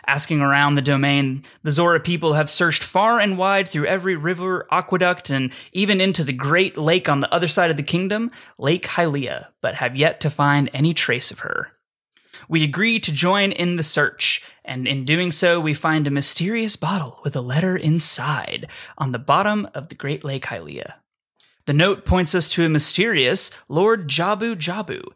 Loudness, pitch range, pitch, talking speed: -19 LUFS, 145-185 Hz, 160 Hz, 185 wpm